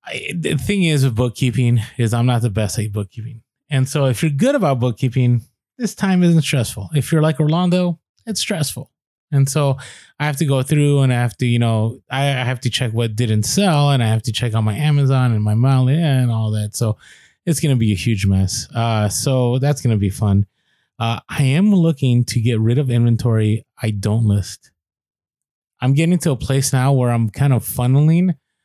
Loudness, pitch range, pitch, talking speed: -17 LUFS, 115-145 Hz, 125 Hz, 215 wpm